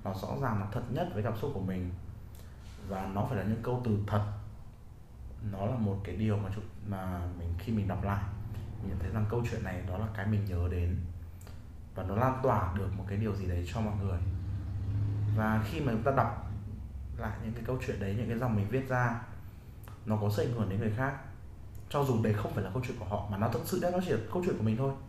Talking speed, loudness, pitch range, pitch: 250 wpm, -34 LUFS, 100-110 Hz, 105 Hz